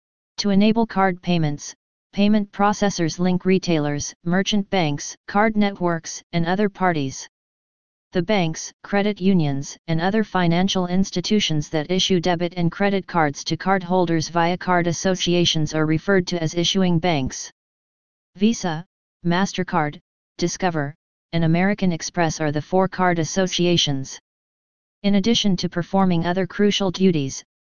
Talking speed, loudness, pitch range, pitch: 125 wpm, -21 LUFS, 165-195 Hz, 180 Hz